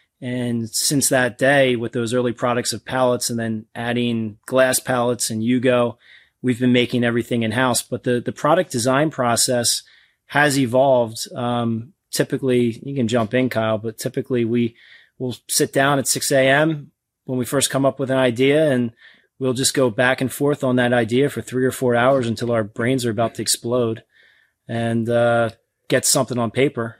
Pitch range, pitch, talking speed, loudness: 115-130 Hz, 125 Hz, 180 wpm, -19 LUFS